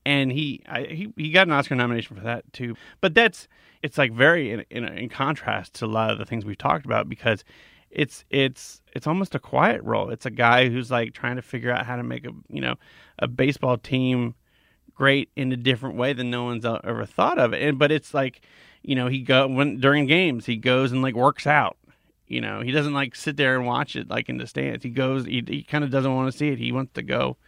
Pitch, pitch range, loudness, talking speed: 130 Hz, 120-140 Hz, -23 LUFS, 250 wpm